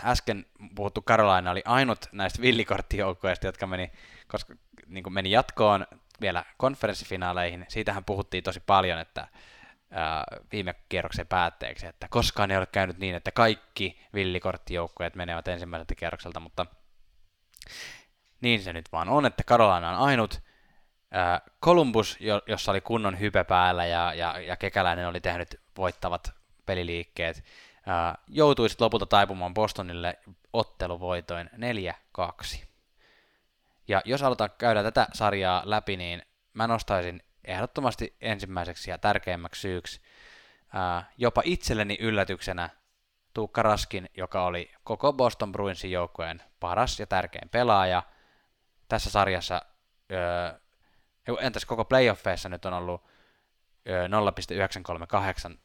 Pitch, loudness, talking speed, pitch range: 95 Hz, -28 LUFS, 120 wpm, 90-105 Hz